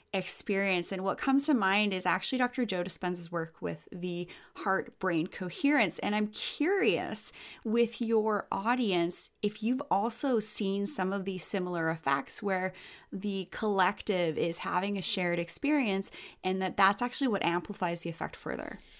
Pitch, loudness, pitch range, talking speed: 195 Hz, -31 LUFS, 180-225 Hz, 155 wpm